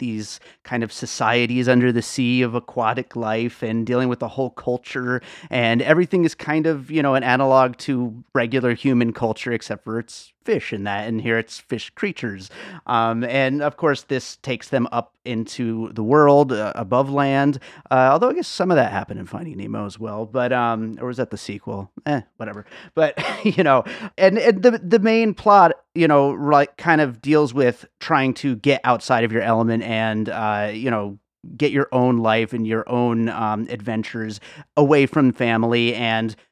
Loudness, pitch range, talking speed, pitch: -20 LUFS, 115-140 Hz, 190 wpm, 125 Hz